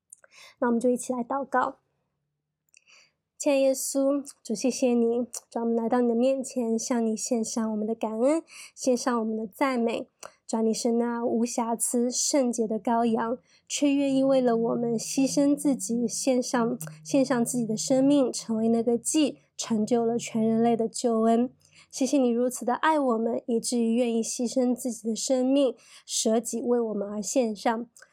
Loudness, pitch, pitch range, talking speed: -26 LUFS, 240 Hz, 230-260 Hz, 250 characters per minute